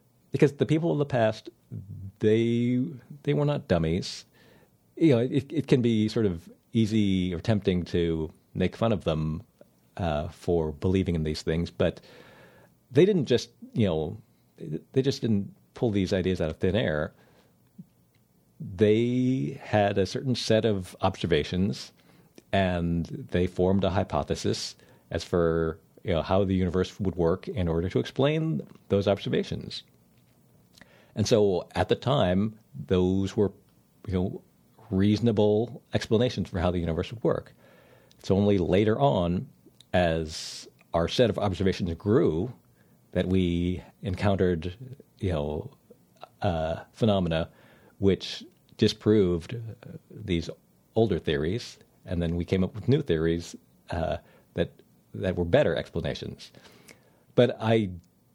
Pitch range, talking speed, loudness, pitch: 90-115 Hz, 135 wpm, -27 LUFS, 100 Hz